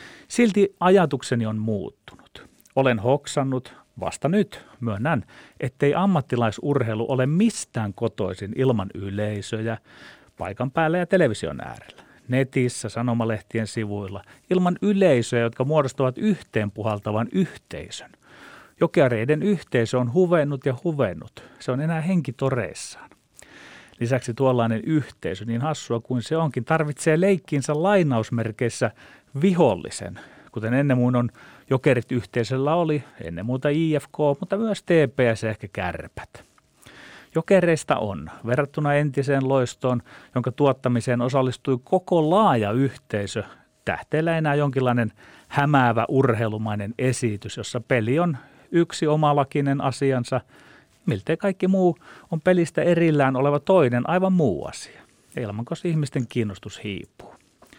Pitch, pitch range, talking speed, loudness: 130 Hz, 115-155 Hz, 115 wpm, -23 LUFS